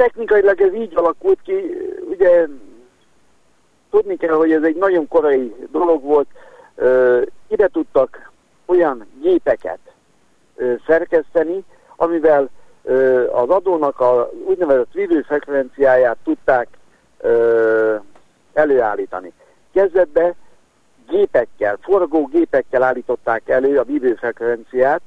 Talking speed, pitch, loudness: 95 wpm, 175 Hz, -17 LUFS